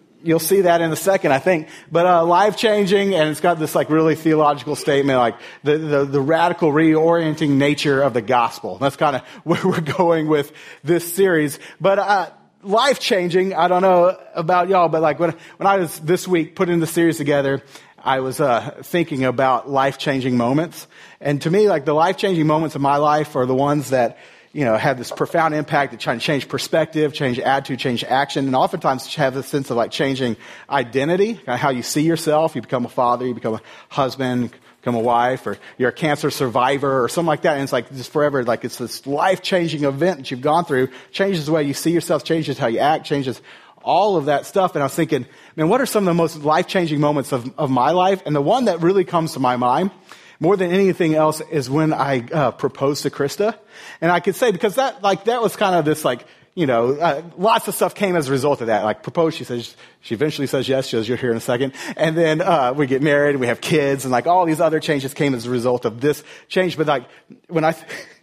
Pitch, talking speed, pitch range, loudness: 150 Hz, 235 wpm, 135-170 Hz, -19 LUFS